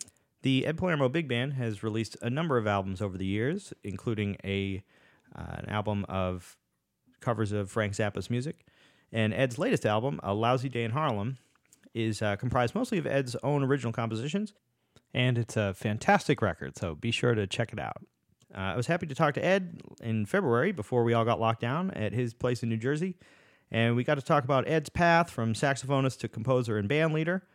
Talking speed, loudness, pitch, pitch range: 200 wpm, -30 LUFS, 120 Hz, 110-145 Hz